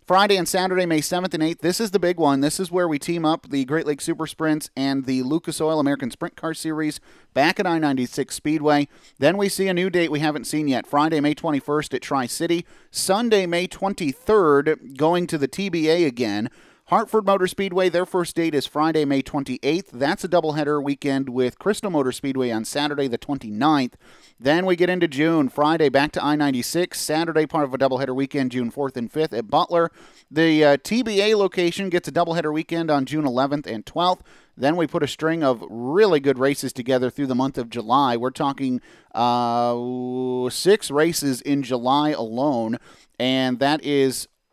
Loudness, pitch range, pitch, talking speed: -22 LUFS, 135-170 Hz, 150 Hz, 190 wpm